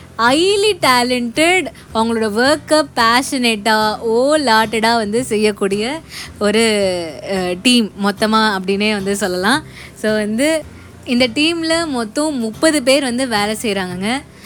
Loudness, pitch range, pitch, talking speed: -15 LUFS, 210-275 Hz, 230 Hz, 105 wpm